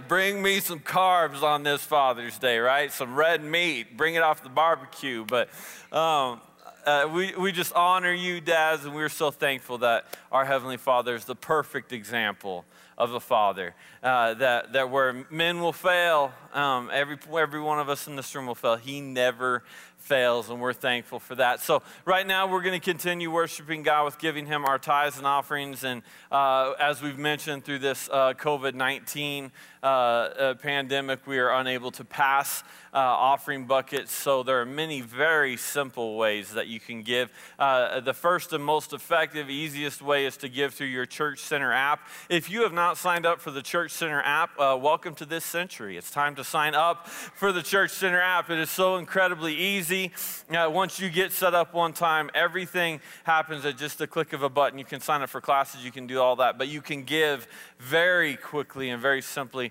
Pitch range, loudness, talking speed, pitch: 135-170 Hz, -26 LUFS, 200 wpm, 145 Hz